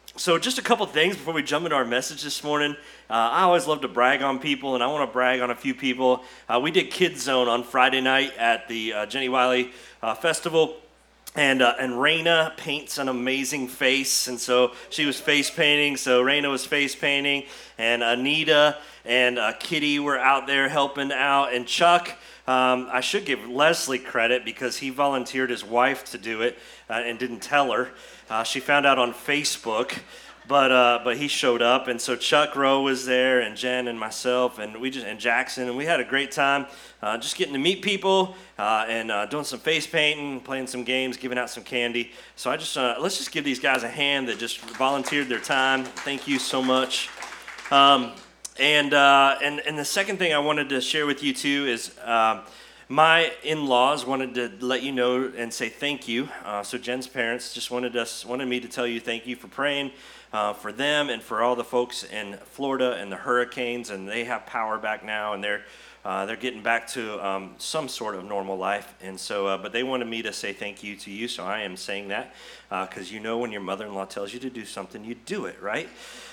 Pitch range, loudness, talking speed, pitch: 120-140 Hz, -24 LUFS, 220 wpm, 130 Hz